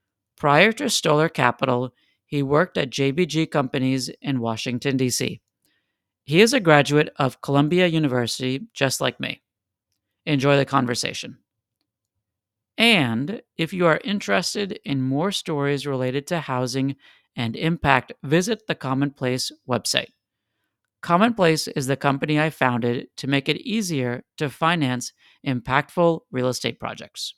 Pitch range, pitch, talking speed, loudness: 125-160 Hz, 140 Hz, 125 wpm, -22 LUFS